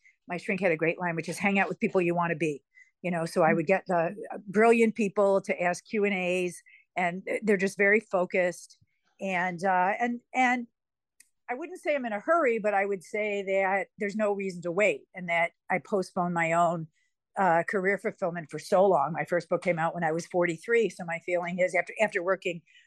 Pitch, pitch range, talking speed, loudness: 185 Hz, 175-210 Hz, 225 wpm, -28 LUFS